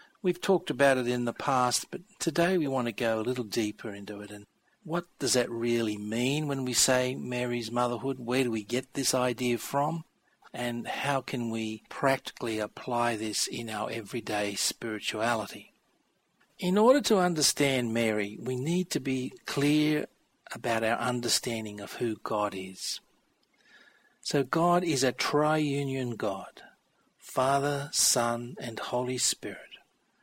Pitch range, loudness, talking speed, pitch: 115-140 Hz, -29 LUFS, 150 wpm, 125 Hz